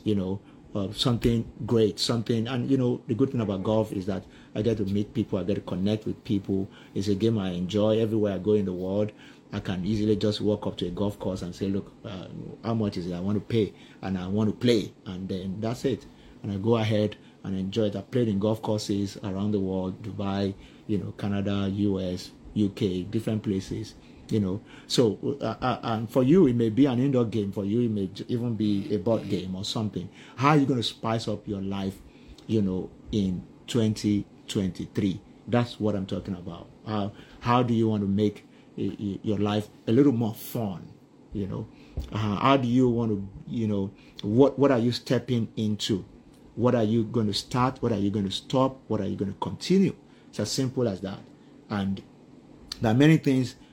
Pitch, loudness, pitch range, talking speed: 105 Hz, -27 LUFS, 100-120 Hz, 220 wpm